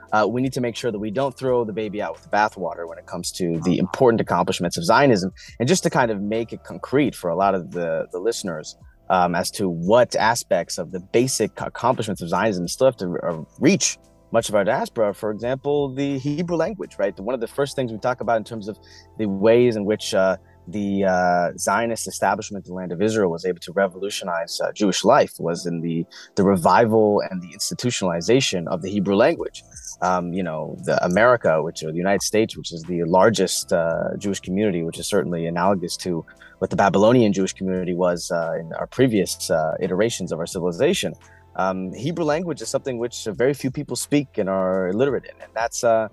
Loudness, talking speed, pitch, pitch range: -22 LUFS, 210 wpm, 105 Hz, 90-125 Hz